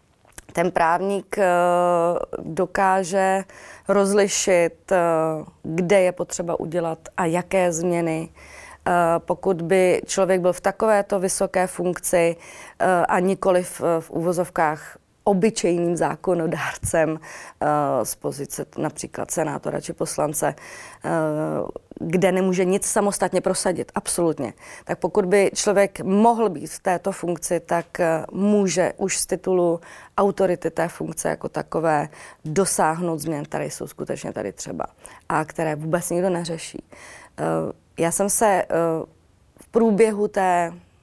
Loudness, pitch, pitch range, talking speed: -22 LUFS, 180 Hz, 165-195 Hz, 115 wpm